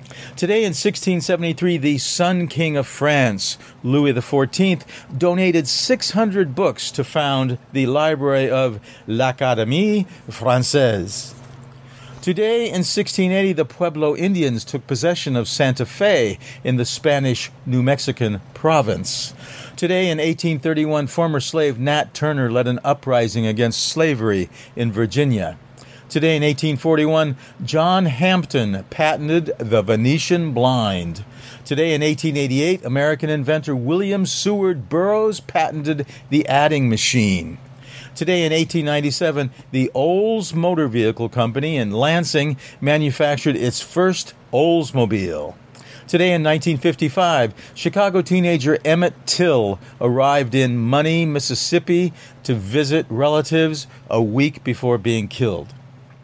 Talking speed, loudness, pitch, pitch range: 110 wpm, -19 LUFS, 145 Hz, 125-165 Hz